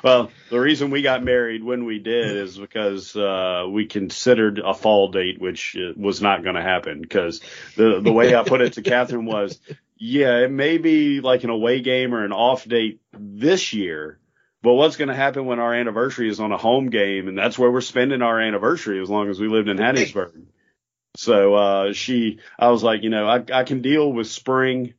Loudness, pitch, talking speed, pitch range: -20 LUFS, 115 Hz, 210 wpm, 105-125 Hz